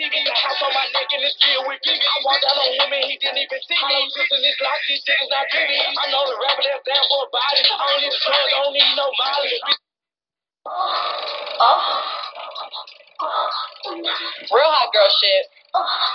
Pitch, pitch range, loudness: 280 Hz, 275-290 Hz, -17 LUFS